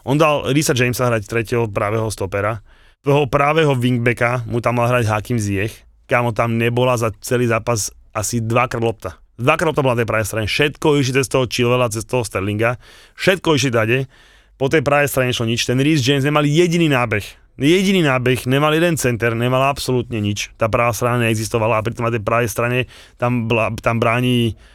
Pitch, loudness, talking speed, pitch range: 120 Hz, -17 LUFS, 190 wpm, 115-135 Hz